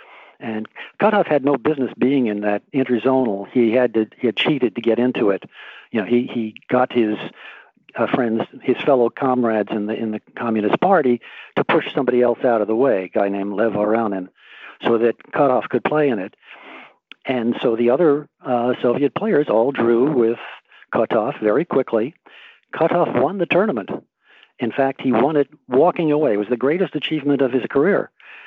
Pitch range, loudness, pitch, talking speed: 115-135 Hz, -19 LUFS, 120 Hz, 185 wpm